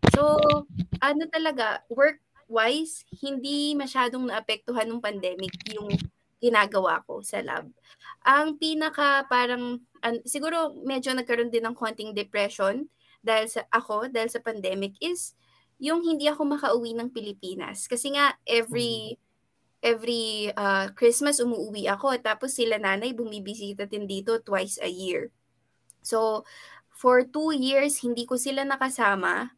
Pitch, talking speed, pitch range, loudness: 235 Hz, 125 wpm, 215-275 Hz, -26 LUFS